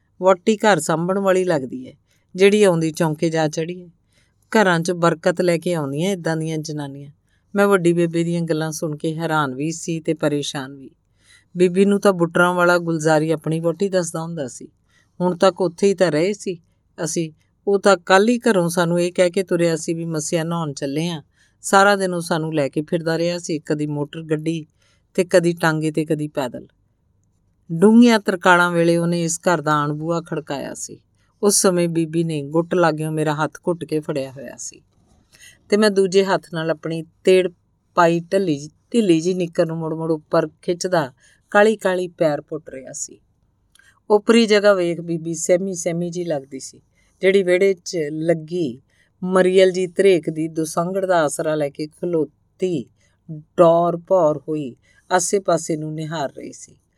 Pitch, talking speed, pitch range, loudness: 170 Hz, 175 wpm, 155-185 Hz, -19 LUFS